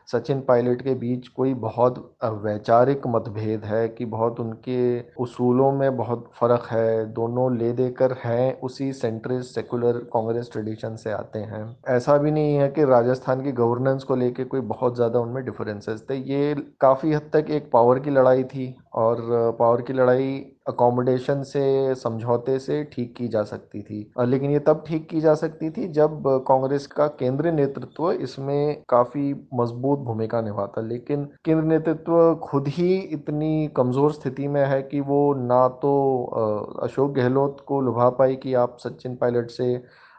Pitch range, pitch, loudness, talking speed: 120-140 Hz, 130 Hz, -23 LUFS, 165 wpm